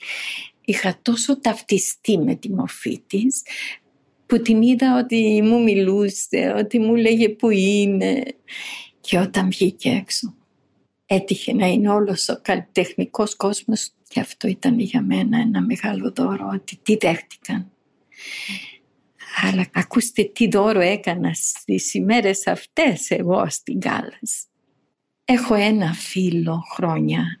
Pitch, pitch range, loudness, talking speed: 215 Hz, 195-235 Hz, -20 LUFS, 120 wpm